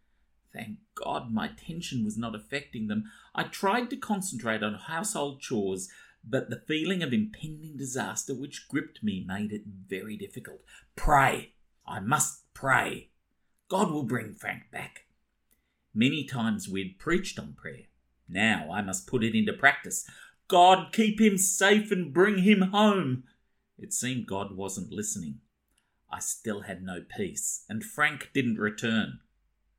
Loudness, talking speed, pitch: -28 LUFS, 145 wpm, 130 Hz